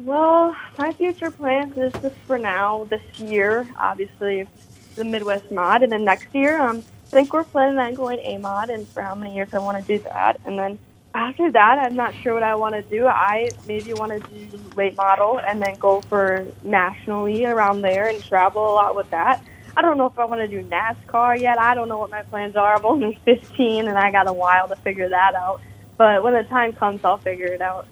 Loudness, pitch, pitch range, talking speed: -20 LUFS, 215 Hz, 195-245 Hz, 230 wpm